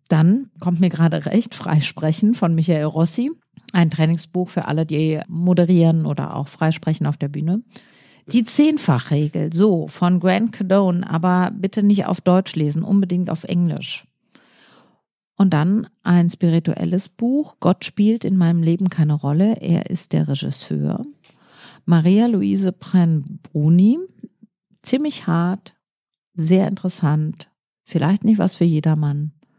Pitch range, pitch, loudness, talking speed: 160-195 Hz, 180 Hz, -19 LUFS, 130 wpm